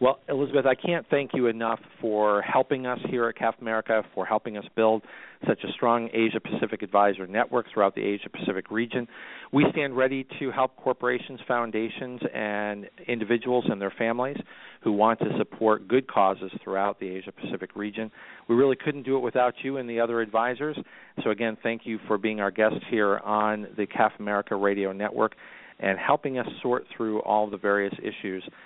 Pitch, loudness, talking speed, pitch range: 115 Hz, -27 LUFS, 185 wpm, 105-125 Hz